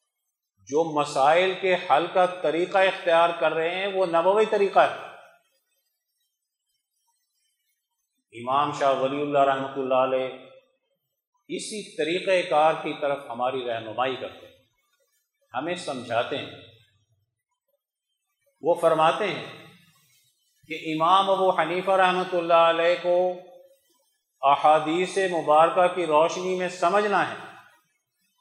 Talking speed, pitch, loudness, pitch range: 110 wpm, 175 Hz, -23 LUFS, 145-205 Hz